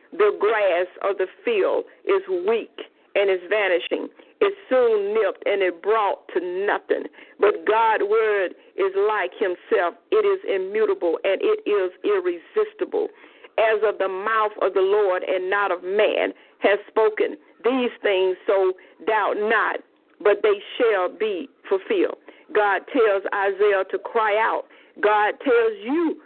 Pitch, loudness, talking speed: 380 Hz, -22 LUFS, 145 wpm